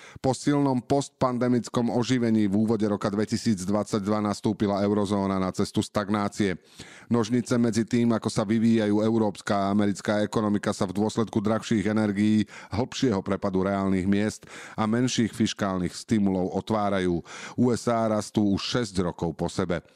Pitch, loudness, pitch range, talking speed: 105 Hz, -26 LUFS, 100-115 Hz, 130 wpm